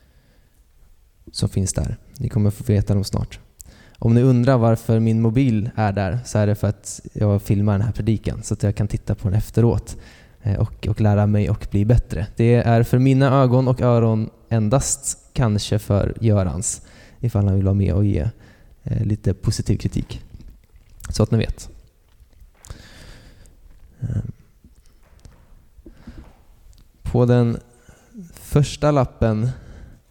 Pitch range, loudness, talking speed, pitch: 100-115 Hz, -20 LUFS, 145 wpm, 110 Hz